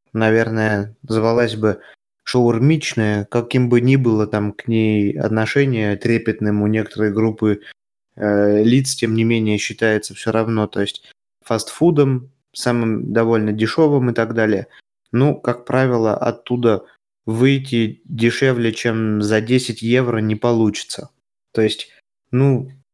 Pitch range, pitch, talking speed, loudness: 110-125 Hz, 115 Hz, 125 wpm, -18 LUFS